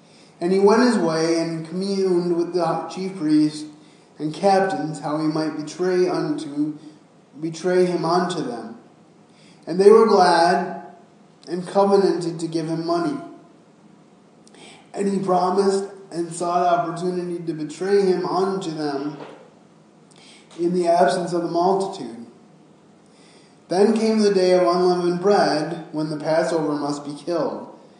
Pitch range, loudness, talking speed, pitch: 165-190 Hz, -21 LUFS, 135 wpm, 175 Hz